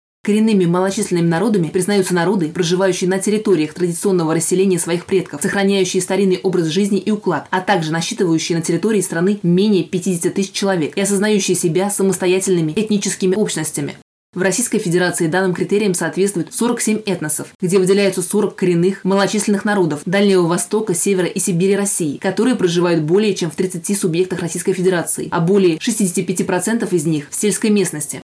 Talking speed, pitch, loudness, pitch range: 150 wpm, 190 Hz, -16 LUFS, 175-200 Hz